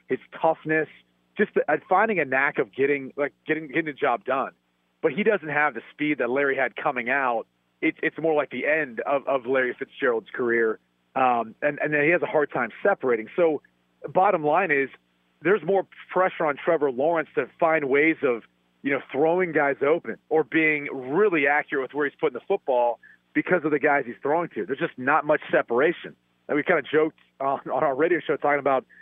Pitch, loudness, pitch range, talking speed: 150 Hz, -24 LUFS, 130-160 Hz, 210 wpm